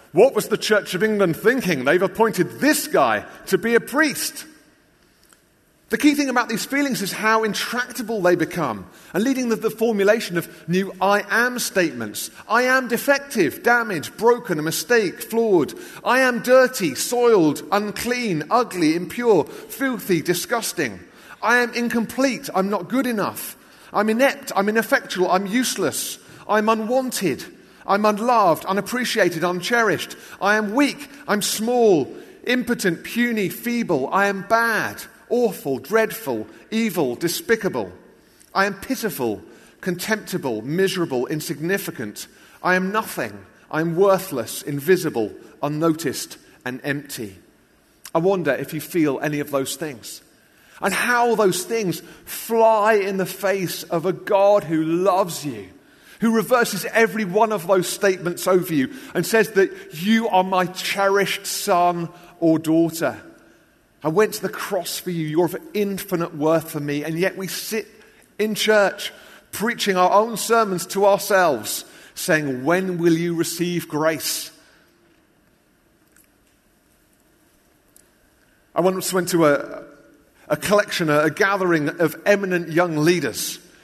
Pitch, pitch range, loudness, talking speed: 195 Hz, 170-230 Hz, -21 LUFS, 135 wpm